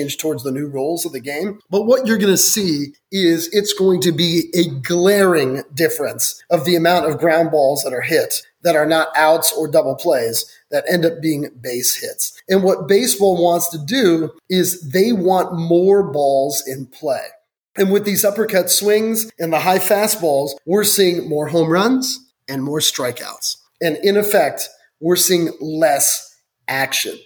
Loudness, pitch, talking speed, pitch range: -16 LUFS, 175 Hz, 175 wpm, 160-205 Hz